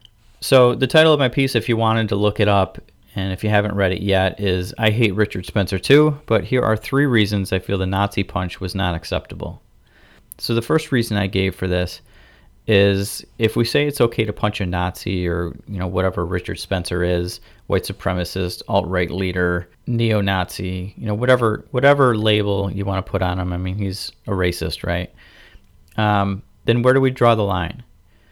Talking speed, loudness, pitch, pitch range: 200 wpm, -19 LUFS, 100 Hz, 90-110 Hz